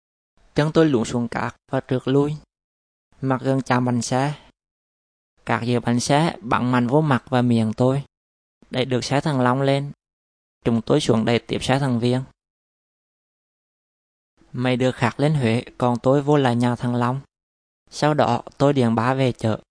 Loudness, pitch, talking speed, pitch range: -21 LUFS, 125 Hz, 175 wpm, 115-135 Hz